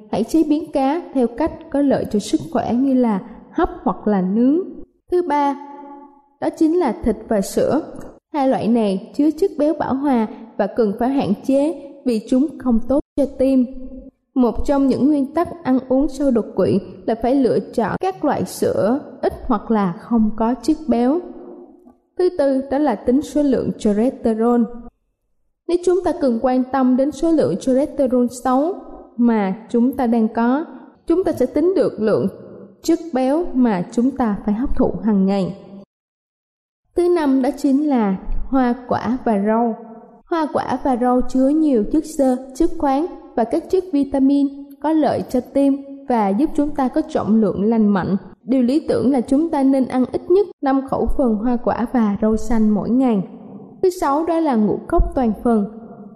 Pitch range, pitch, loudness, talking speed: 230-290 Hz, 260 Hz, -19 LUFS, 185 wpm